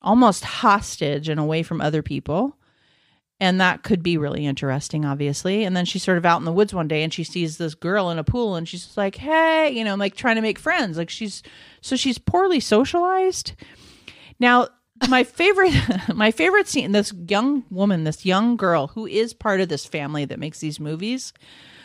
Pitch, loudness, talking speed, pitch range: 195 Hz, -21 LUFS, 200 wpm, 160-240 Hz